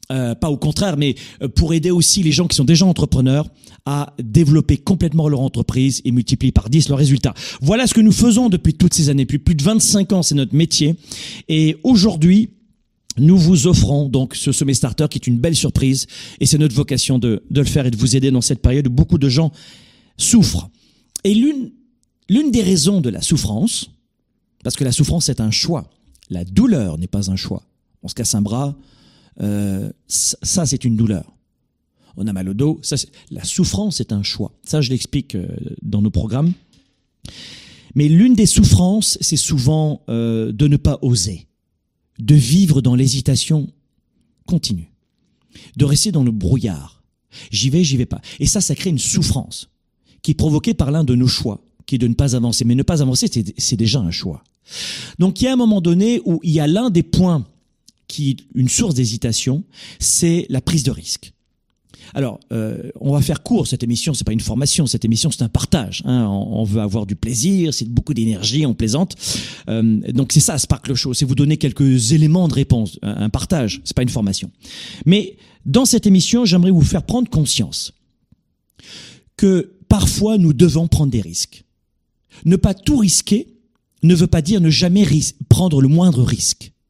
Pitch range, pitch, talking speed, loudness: 120-170 Hz, 140 Hz, 195 wpm, -16 LUFS